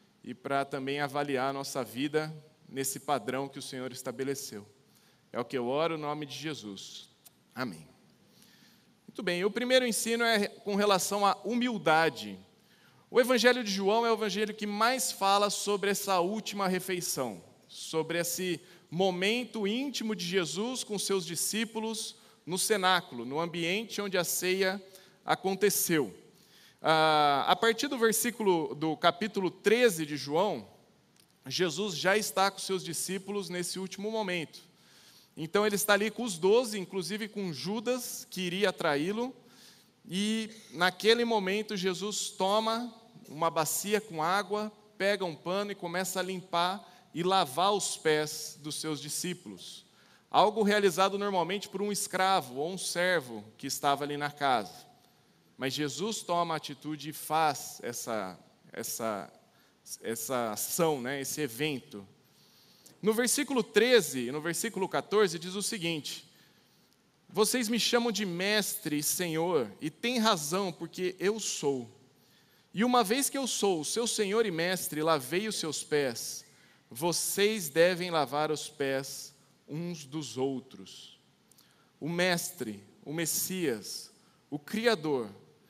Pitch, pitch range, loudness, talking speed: 185 Hz, 155-210 Hz, -30 LUFS, 140 wpm